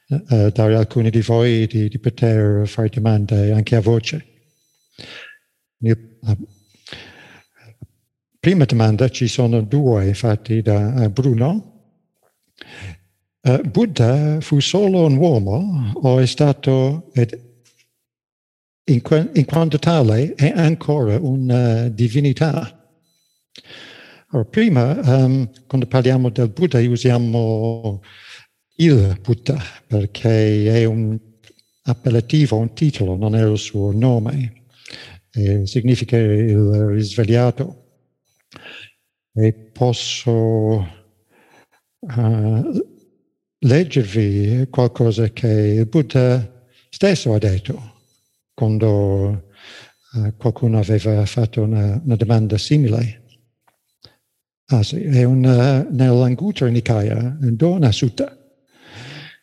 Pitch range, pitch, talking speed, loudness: 110-135 Hz, 120 Hz, 95 wpm, -17 LUFS